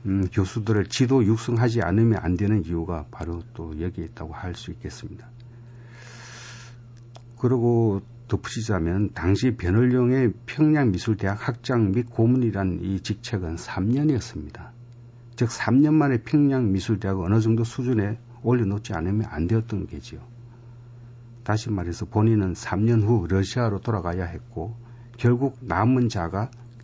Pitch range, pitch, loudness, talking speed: 100-120 Hz, 115 Hz, -24 LUFS, 290 characters per minute